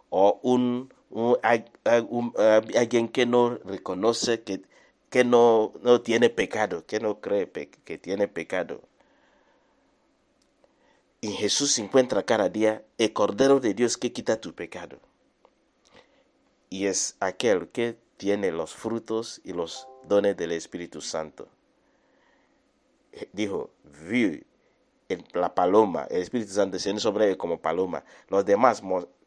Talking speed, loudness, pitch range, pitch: 135 wpm, -25 LUFS, 100-120 Hz, 115 Hz